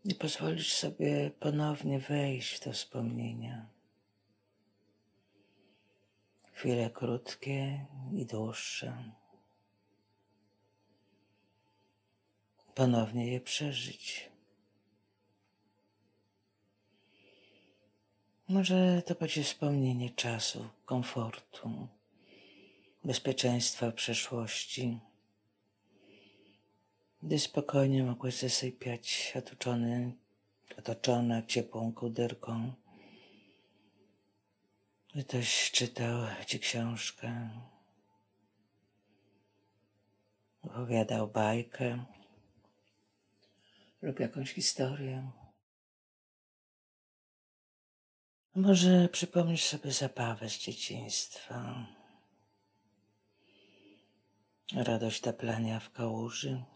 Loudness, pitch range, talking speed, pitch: -34 LUFS, 100-125 Hz, 55 wpm, 105 Hz